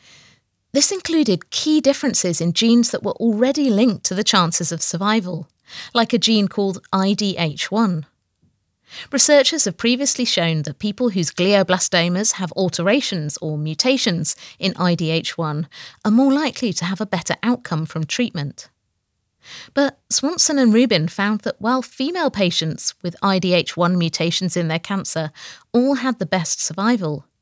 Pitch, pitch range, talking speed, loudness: 195 Hz, 170-245 Hz, 140 wpm, -19 LUFS